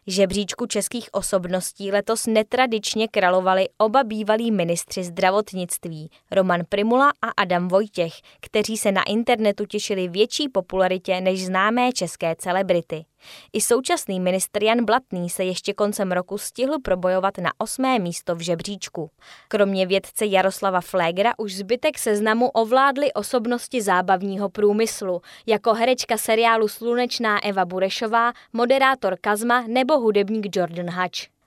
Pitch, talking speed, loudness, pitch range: 205 Hz, 125 wpm, -21 LUFS, 185-230 Hz